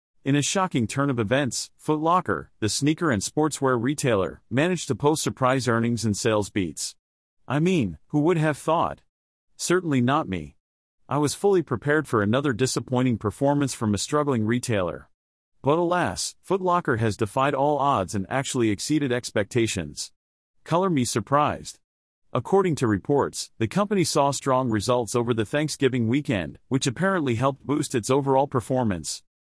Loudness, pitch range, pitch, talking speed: -24 LUFS, 115-150 Hz, 135 Hz, 150 wpm